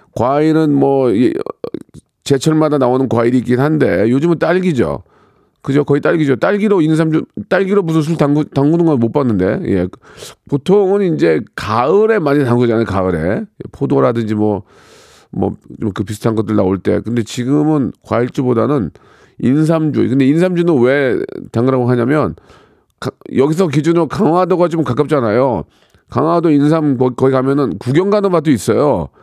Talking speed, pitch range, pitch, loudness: 315 characters per minute, 125-165 Hz, 145 Hz, -14 LUFS